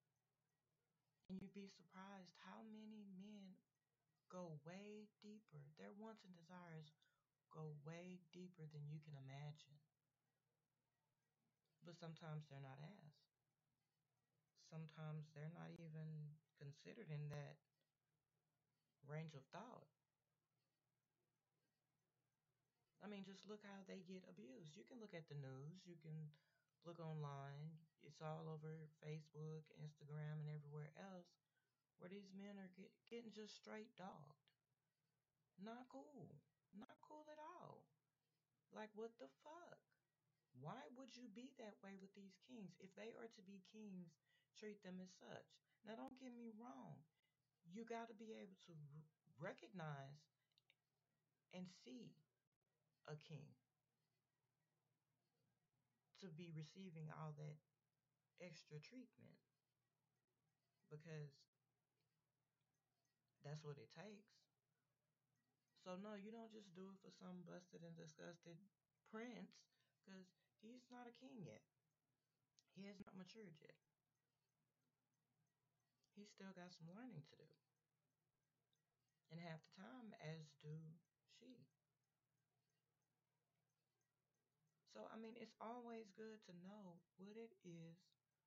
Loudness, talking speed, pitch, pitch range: -60 LUFS, 120 wpm, 155 Hz, 145-190 Hz